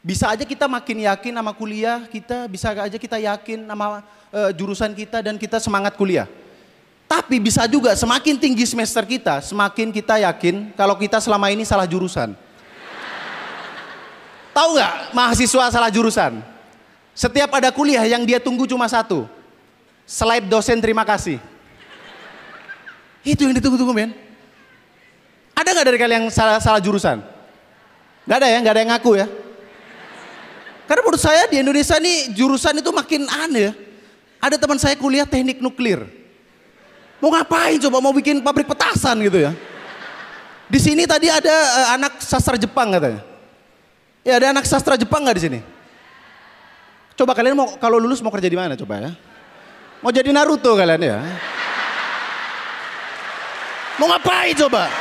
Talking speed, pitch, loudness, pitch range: 145 wpm, 235 Hz, -17 LUFS, 210-270 Hz